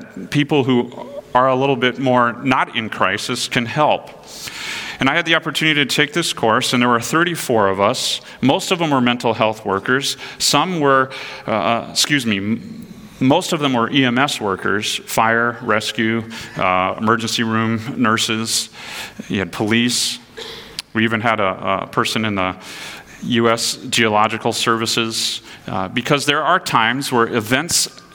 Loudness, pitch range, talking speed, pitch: -17 LUFS, 110-140 Hz, 155 wpm, 120 Hz